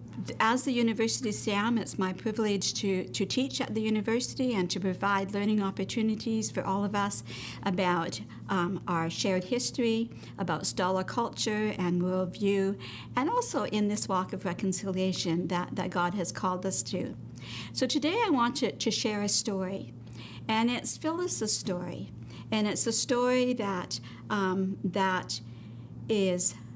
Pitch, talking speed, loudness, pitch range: 200 Hz, 150 wpm, -30 LUFS, 185-225 Hz